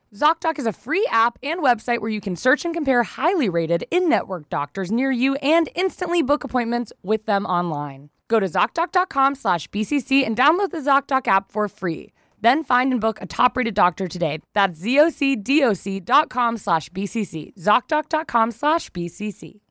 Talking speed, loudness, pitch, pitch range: 145 wpm, -21 LUFS, 240 Hz, 195-290 Hz